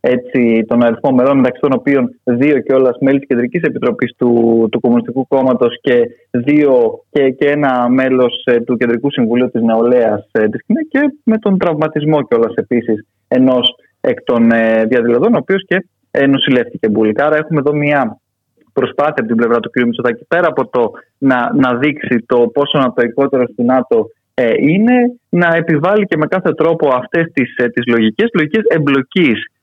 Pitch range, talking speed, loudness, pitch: 120-155 Hz, 180 wpm, -13 LUFS, 130 Hz